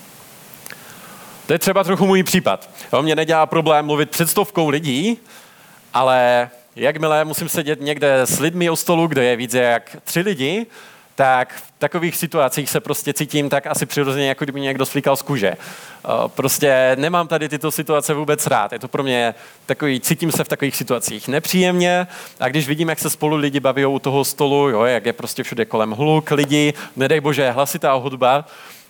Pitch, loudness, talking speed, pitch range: 150 Hz, -18 LUFS, 180 wpm, 135-165 Hz